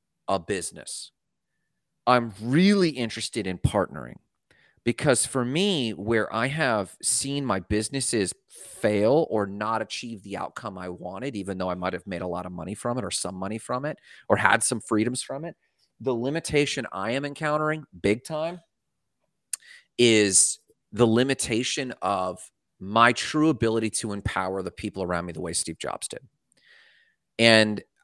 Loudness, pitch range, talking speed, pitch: -25 LUFS, 100-130 Hz, 155 wpm, 115 Hz